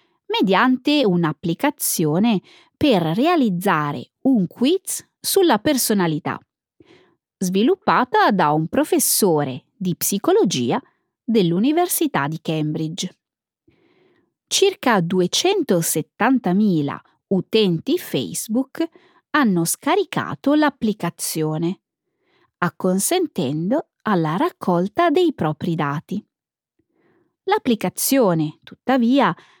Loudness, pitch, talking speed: -19 LUFS, 220 Hz, 65 wpm